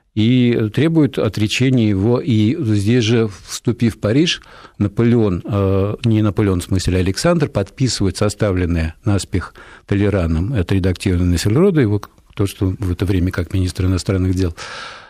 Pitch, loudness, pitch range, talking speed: 105 Hz, -17 LUFS, 95-115 Hz, 140 wpm